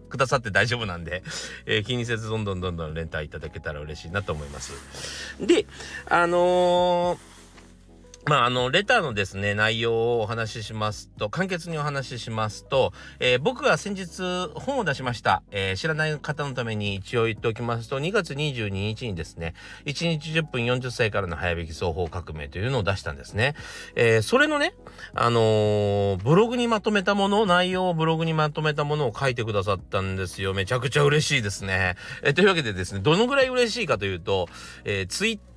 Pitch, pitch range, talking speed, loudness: 120 Hz, 100-160 Hz, 365 characters per minute, -24 LUFS